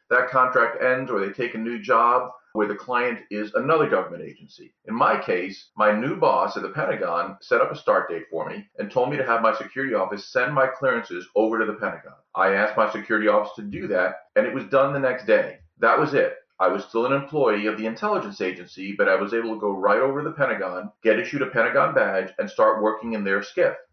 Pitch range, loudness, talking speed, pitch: 105-140 Hz, -23 LUFS, 240 wpm, 115 Hz